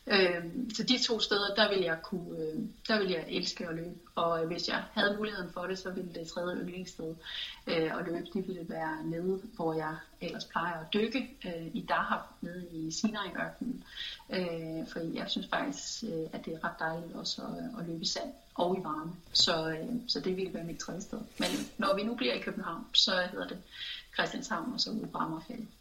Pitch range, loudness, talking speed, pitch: 170-220 Hz, -34 LUFS, 190 wpm, 185 Hz